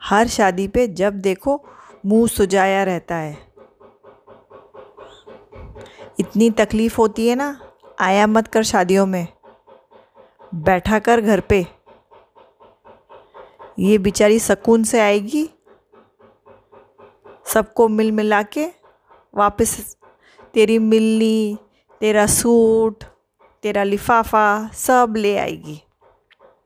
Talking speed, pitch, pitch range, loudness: 95 wpm, 220 Hz, 205-235 Hz, -17 LUFS